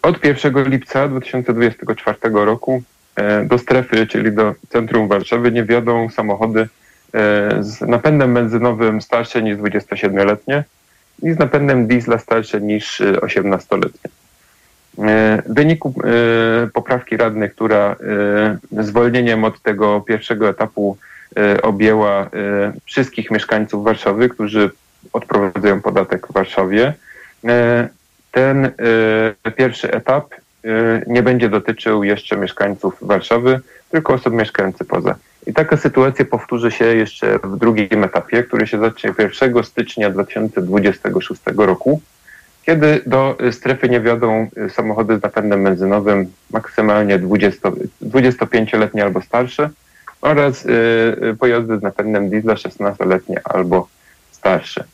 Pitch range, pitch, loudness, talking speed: 105-125 Hz, 115 Hz, -16 LUFS, 110 wpm